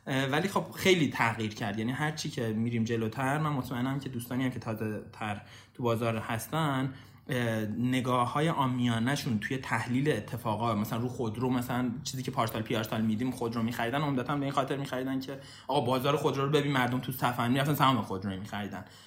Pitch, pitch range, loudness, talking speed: 125 Hz, 115-135 Hz, -31 LUFS, 180 wpm